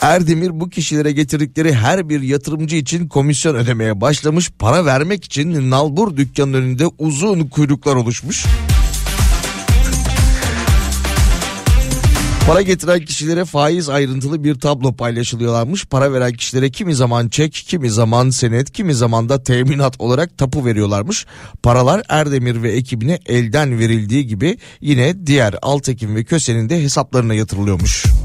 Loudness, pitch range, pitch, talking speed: -15 LUFS, 120-155 Hz, 140 Hz, 125 wpm